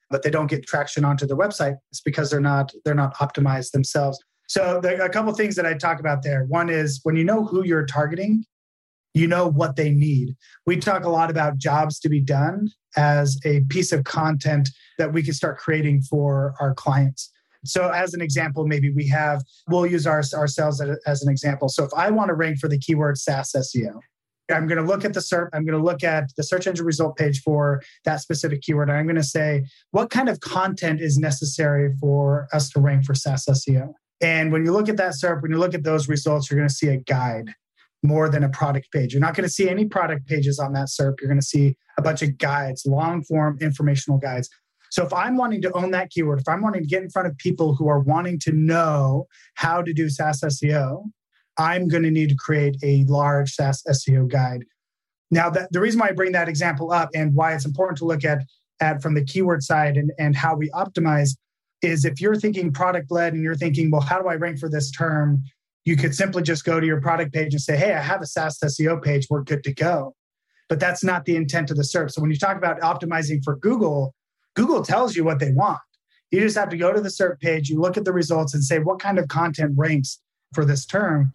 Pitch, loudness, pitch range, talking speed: 155 Hz, -22 LUFS, 145-170 Hz, 240 wpm